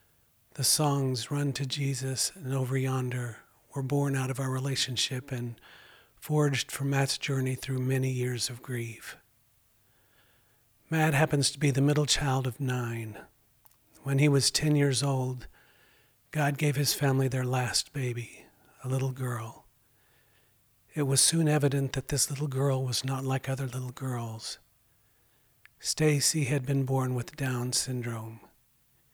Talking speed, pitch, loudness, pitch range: 145 wpm, 130 Hz, -29 LUFS, 120-140 Hz